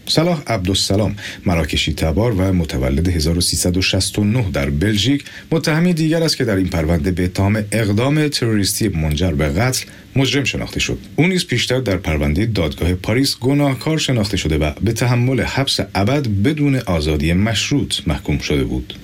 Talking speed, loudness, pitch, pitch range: 150 wpm, -17 LUFS, 100 Hz, 90-130 Hz